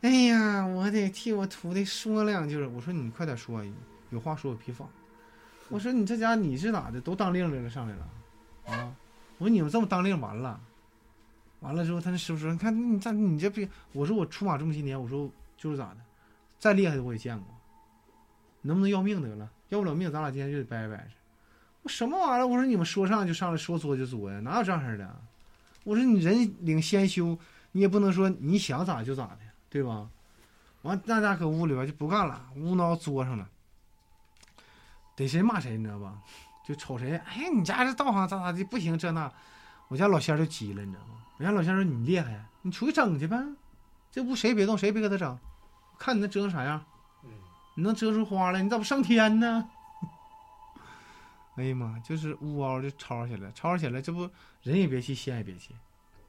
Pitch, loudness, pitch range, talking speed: 165 Hz, -29 LUFS, 120-200 Hz, 295 characters per minute